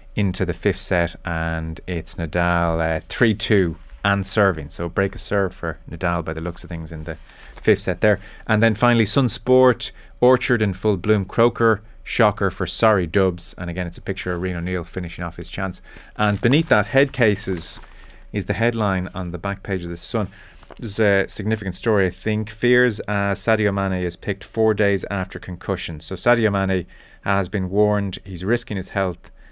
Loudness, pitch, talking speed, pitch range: -21 LUFS, 95 Hz, 195 wpm, 90-110 Hz